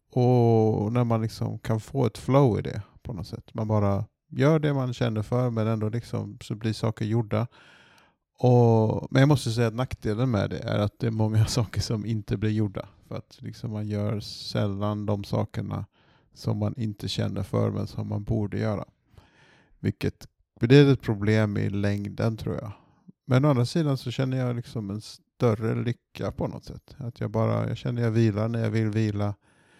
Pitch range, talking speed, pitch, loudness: 105-125 Hz, 195 wpm, 115 Hz, -26 LUFS